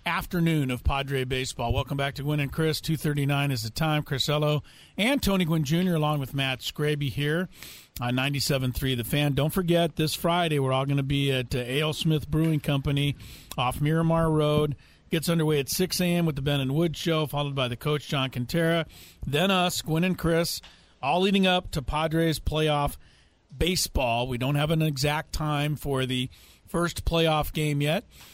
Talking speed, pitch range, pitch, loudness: 180 wpm, 135-165 Hz, 150 Hz, -26 LUFS